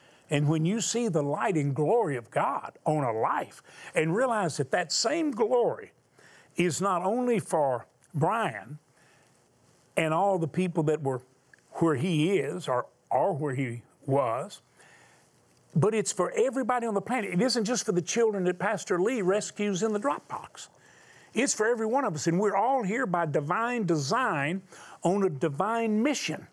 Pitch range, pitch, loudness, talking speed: 155-225 Hz, 185 Hz, -28 LUFS, 170 wpm